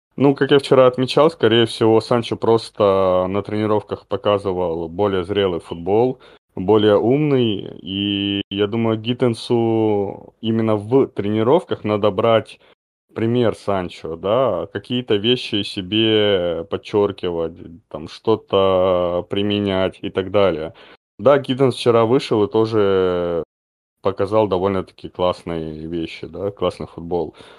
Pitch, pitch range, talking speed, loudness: 105 Hz, 95-115 Hz, 115 wpm, -19 LUFS